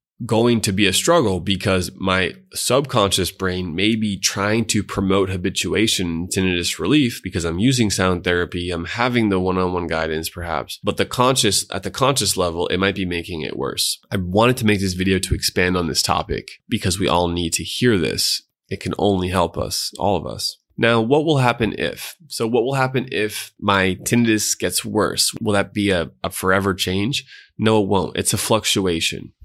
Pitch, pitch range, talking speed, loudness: 95 Hz, 90-110 Hz, 195 wpm, -19 LUFS